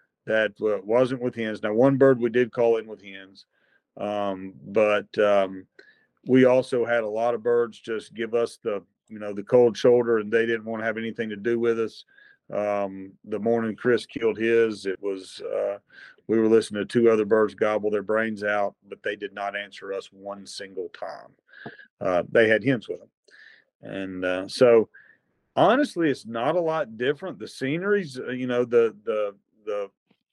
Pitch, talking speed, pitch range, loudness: 115 Hz, 185 wpm, 105-120 Hz, -24 LUFS